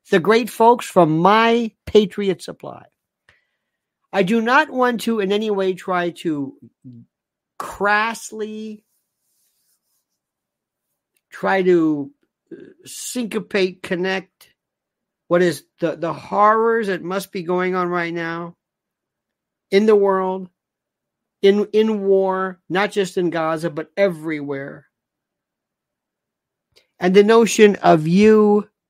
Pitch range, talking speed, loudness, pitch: 175-215 Hz, 105 wpm, -18 LUFS, 195 Hz